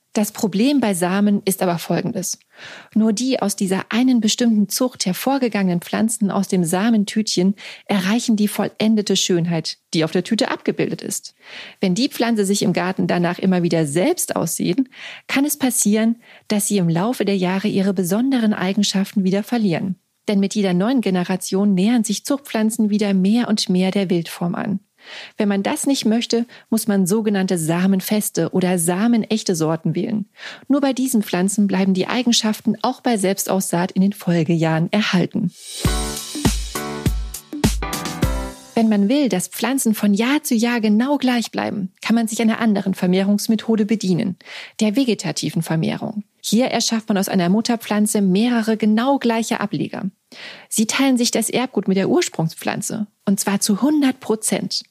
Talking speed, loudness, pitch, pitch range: 155 wpm, -19 LUFS, 210 Hz, 190-230 Hz